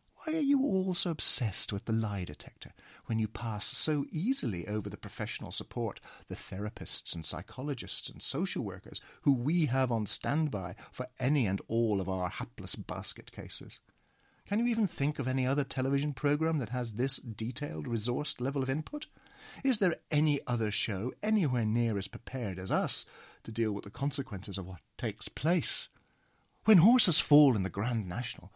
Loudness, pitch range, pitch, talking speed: -32 LUFS, 105-145 Hz, 120 Hz, 175 wpm